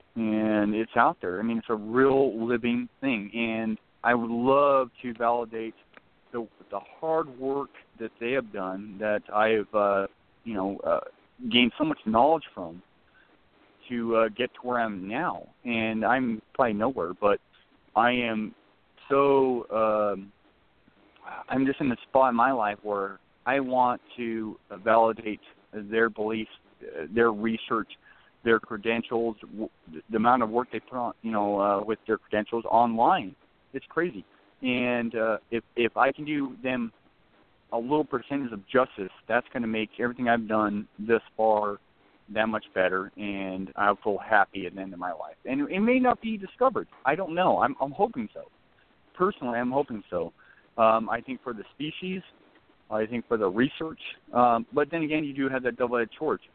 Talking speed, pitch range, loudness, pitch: 170 wpm, 105-130 Hz, -27 LUFS, 115 Hz